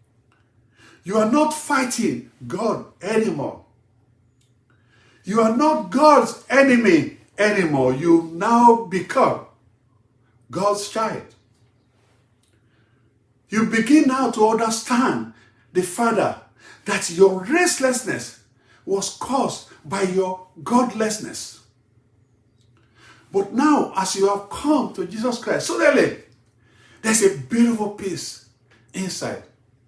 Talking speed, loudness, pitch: 95 wpm, -20 LUFS, 185 Hz